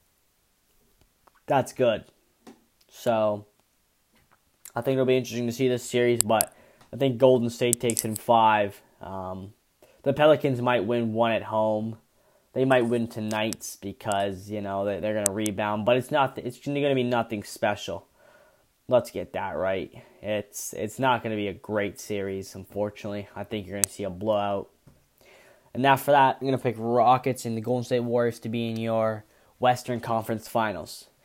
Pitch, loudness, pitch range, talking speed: 115 Hz, -26 LUFS, 105-125 Hz, 175 wpm